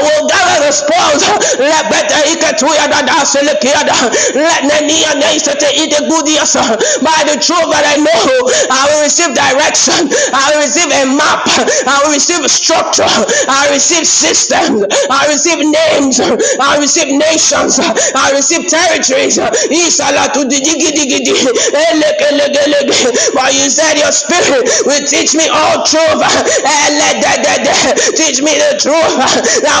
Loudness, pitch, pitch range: -8 LUFS, 300 Hz, 285-320 Hz